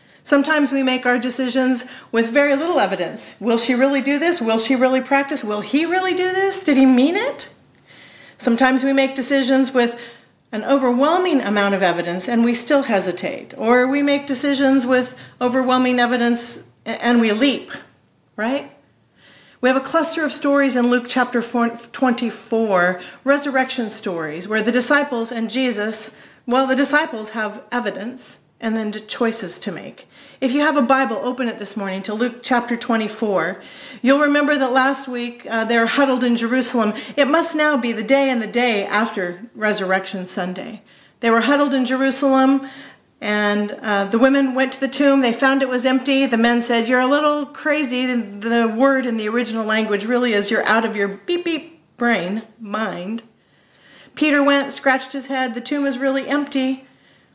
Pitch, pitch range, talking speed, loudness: 250 Hz, 225-275 Hz, 175 wpm, -18 LUFS